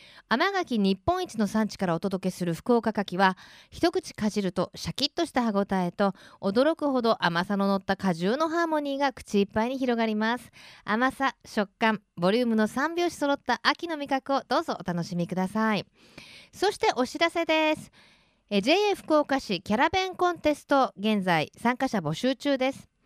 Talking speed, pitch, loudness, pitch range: 345 characters per minute, 235 Hz, -27 LUFS, 200-290 Hz